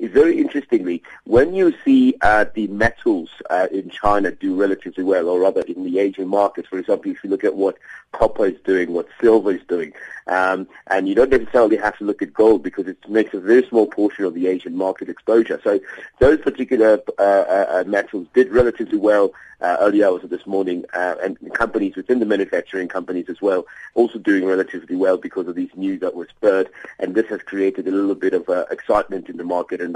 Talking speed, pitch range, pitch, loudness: 210 wpm, 95-125 Hz, 105 Hz, -19 LUFS